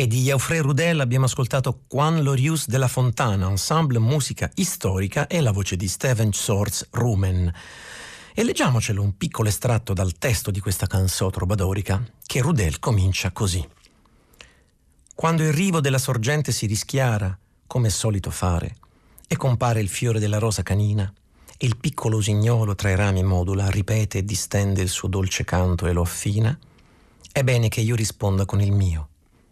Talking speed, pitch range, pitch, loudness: 165 wpm, 95-125 Hz, 105 Hz, -22 LUFS